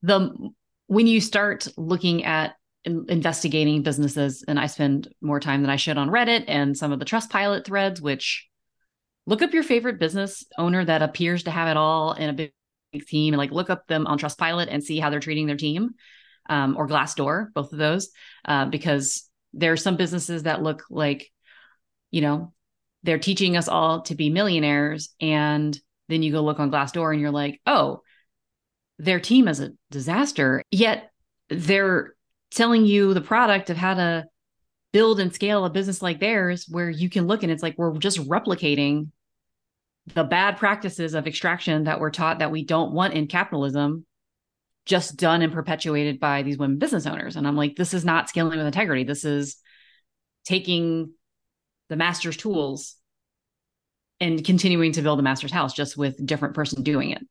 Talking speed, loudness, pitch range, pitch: 185 wpm, -23 LUFS, 150-185 Hz, 160 Hz